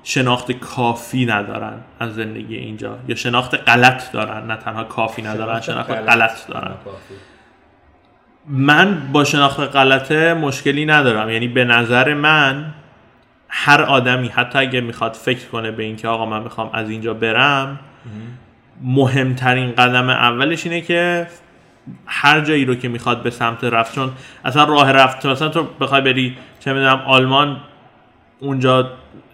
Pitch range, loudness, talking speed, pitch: 115-140 Hz, -15 LUFS, 140 wpm, 125 Hz